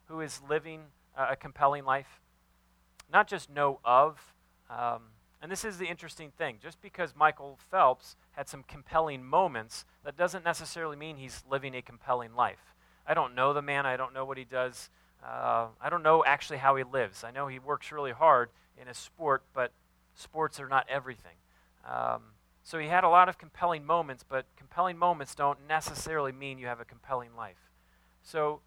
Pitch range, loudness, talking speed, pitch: 115-155 Hz, -30 LUFS, 185 wpm, 135 Hz